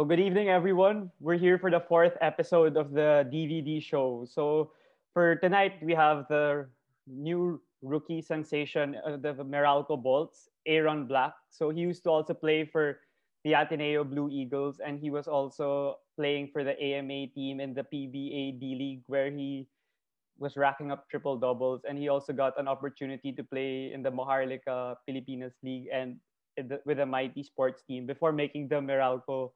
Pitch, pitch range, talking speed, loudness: 145 Hz, 135-155 Hz, 175 wpm, -30 LUFS